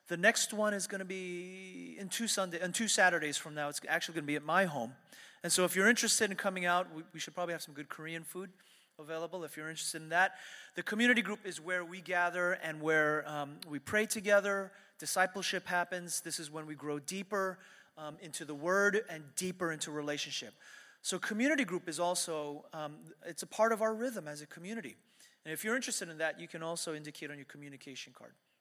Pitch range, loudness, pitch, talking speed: 155-195 Hz, -34 LUFS, 175 Hz, 220 wpm